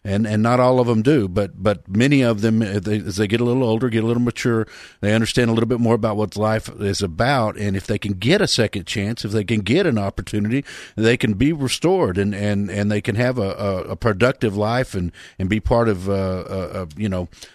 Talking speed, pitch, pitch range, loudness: 245 wpm, 110 Hz, 100-120 Hz, -20 LUFS